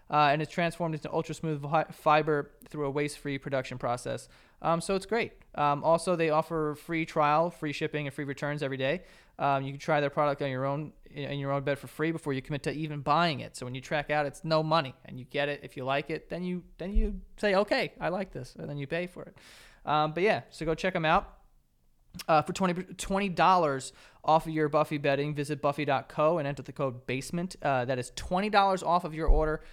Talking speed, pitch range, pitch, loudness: 235 wpm, 140-165 Hz, 150 Hz, -30 LUFS